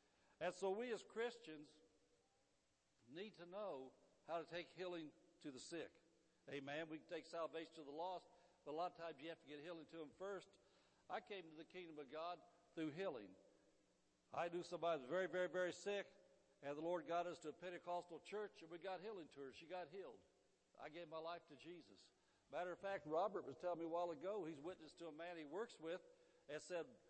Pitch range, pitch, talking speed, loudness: 160-180 Hz, 170 Hz, 220 wpm, -51 LUFS